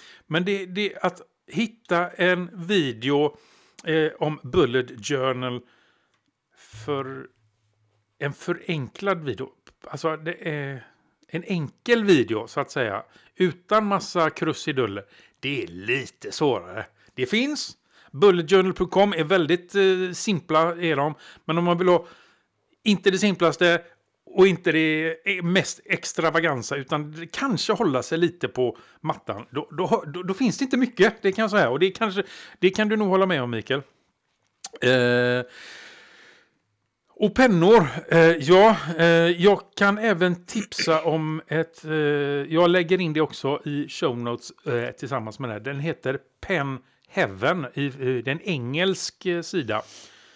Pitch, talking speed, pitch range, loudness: 165 Hz, 140 wpm, 140-190 Hz, -23 LUFS